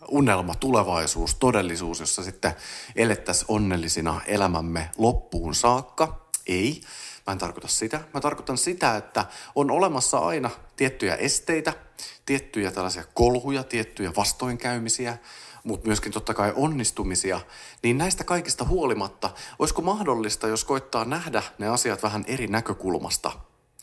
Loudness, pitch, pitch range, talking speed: -25 LUFS, 110 Hz, 90-125 Hz, 120 wpm